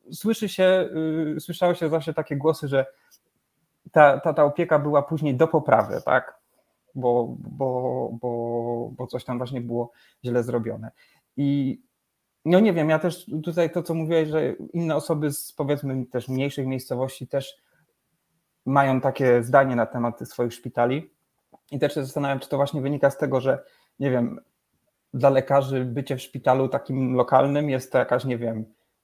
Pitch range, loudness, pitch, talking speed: 125-155 Hz, -24 LUFS, 140 Hz, 165 wpm